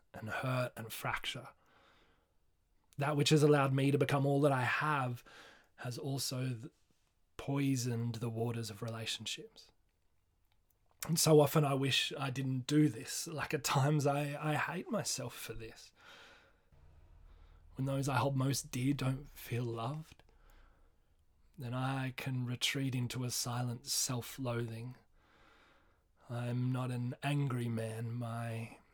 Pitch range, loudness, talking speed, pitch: 115-140 Hz, -35 LUFS, 135 wpm, 125 Hz